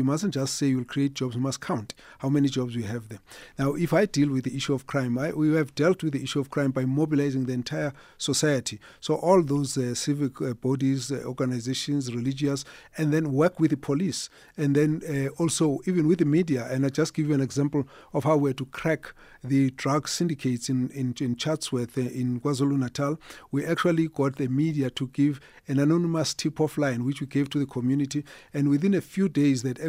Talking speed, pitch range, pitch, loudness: 215 wpm, 135-155 Hz, 140 Hz, -26 LUFS